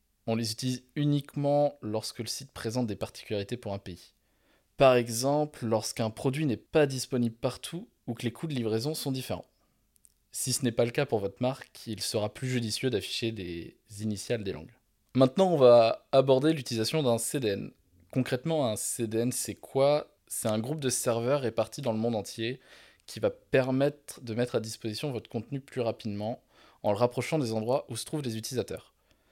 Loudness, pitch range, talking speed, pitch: -29 LUFS, 110-135 Hz, 185 wpm, 120 Hz